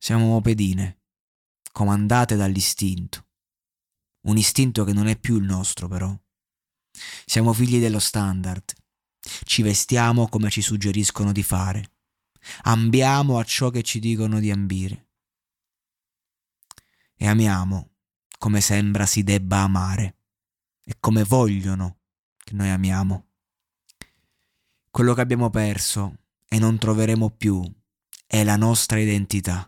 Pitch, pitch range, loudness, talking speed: 105 Hz, 95-110 Hz, -21 LUFS, 115 wpm